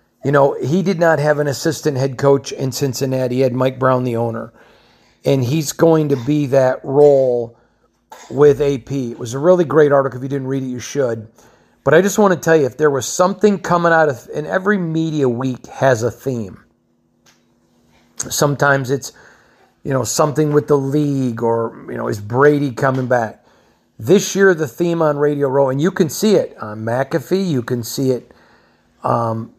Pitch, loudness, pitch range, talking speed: 135 Hz, -16 LUFS, 125-155 Hz, 195 wpm